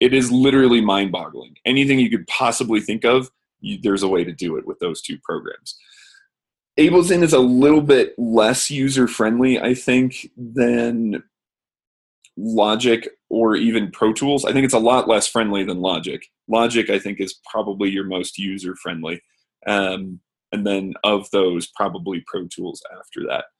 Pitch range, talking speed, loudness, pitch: 100-130 Hz, 170 wpm, -18 LUFS, 115 Hz